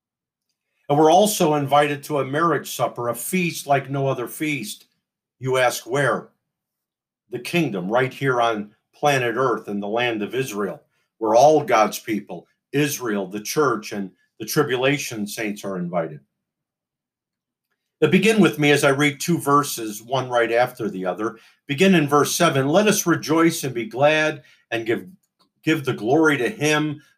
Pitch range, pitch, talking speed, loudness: 115-155 Hz, 140 Hz, 160 wpm, -20 LUFS